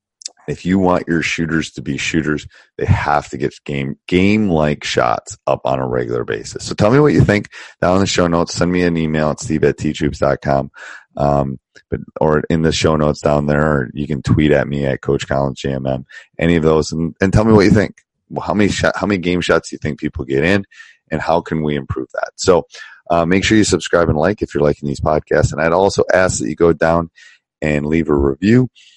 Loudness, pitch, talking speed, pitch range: -16 LUFS, 80 Hz, 230 wpm, 75-90 Hz